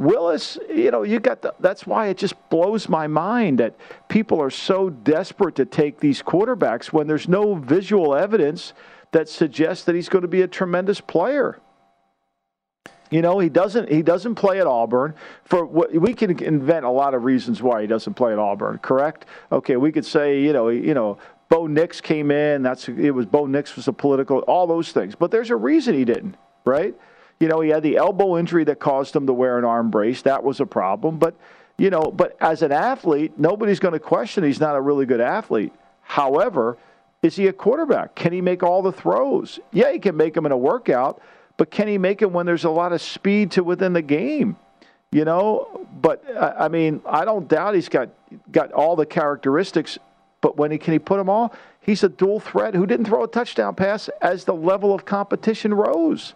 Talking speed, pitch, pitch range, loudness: 215 wpm, 170 Hz, 145-200 Hz, -20 LUFS